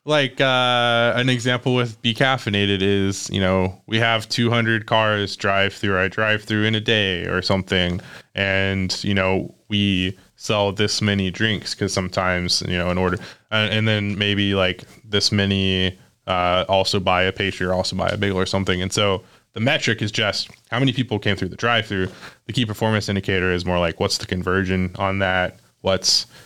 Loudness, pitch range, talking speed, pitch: -20 LUFS, 95-110 Hz, 190 wpm, 100 Hz